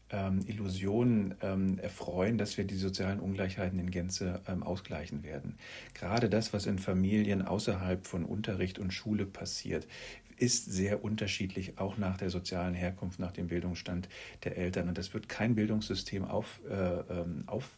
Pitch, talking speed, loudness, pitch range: 95 Hz, 145 wpm, -34 LUFS, 90-105 Hz